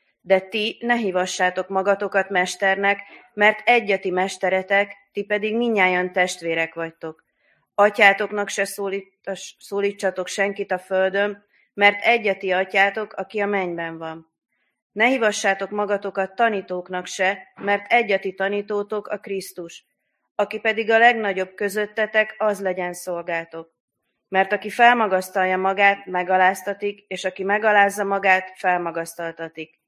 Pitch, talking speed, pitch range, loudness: 195 Hz, 110 wpm, 185-205 Hz, -21 LUFS